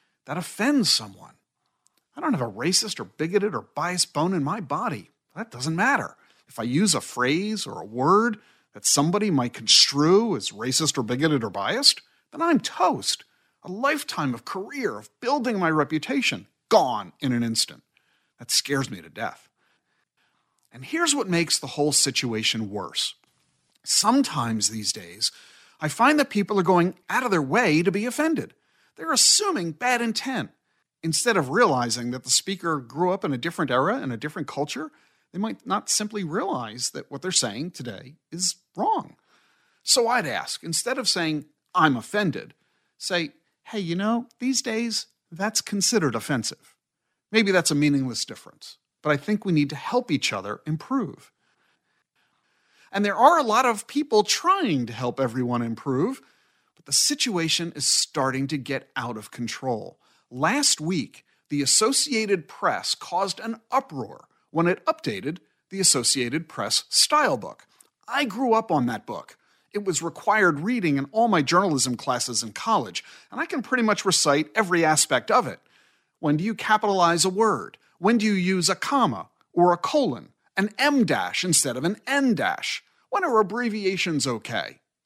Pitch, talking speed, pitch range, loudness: 180 Hz, 165 wpm, 145-225 Hz, -23 LUFS